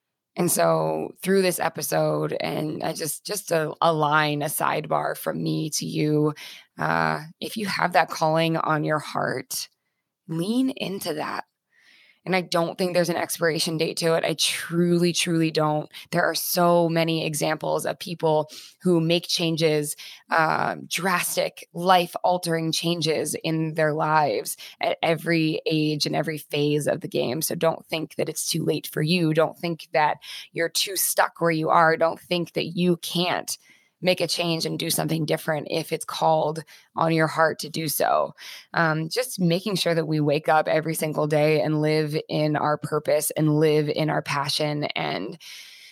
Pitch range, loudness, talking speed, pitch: 155-170 Hz, -24 LUFS, 170 wpm, 160 Hz